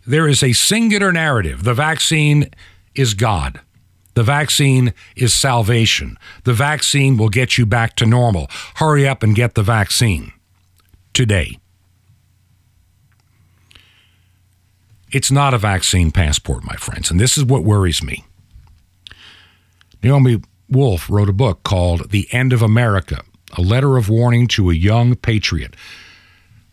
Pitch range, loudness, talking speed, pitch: 90-125 Hz, -15 LUFS, 130 wpm, 110 Hz